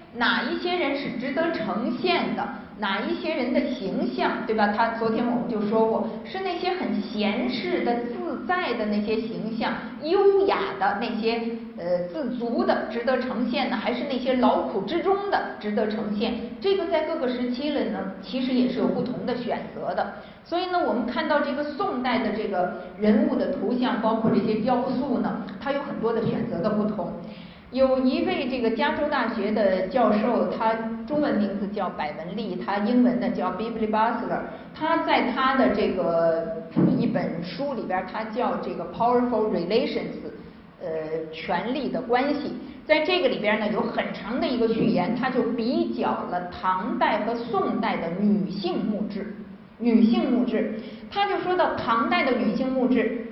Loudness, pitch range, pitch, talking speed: -25 LUFS, 215-265 Hz, 230 Hz, 275 characters per minute